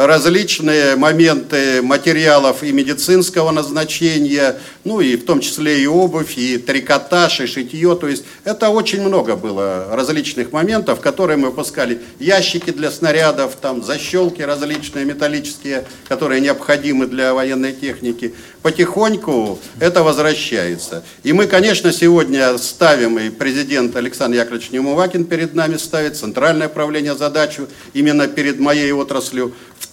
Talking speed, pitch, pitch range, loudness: 130 wpm, 145 Hz, 130-160 Hz, -15 LUFS